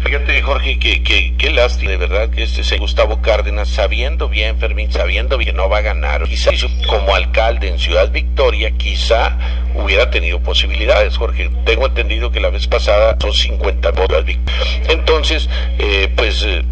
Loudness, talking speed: -15 LUFS, 170 wpm